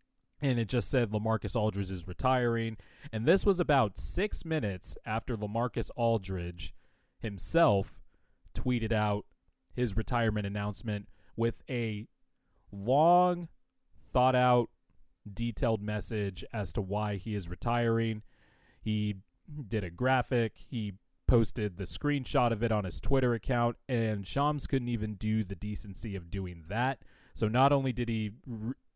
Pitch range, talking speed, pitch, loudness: 100-125 Hz, 135 wpm, 110 Hz, -31 LUFS